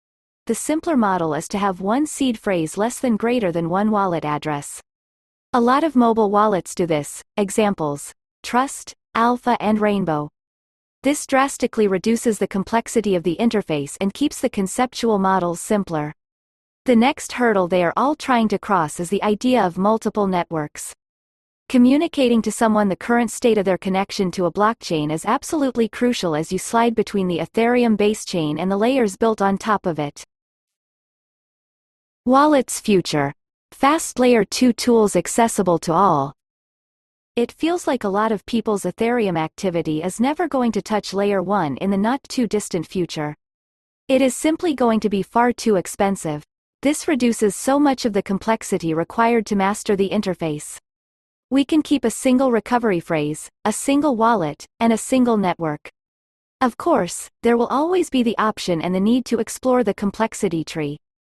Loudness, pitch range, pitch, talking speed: -20 LUFS, 180-245 Hz, 210 Hz, 165 wpm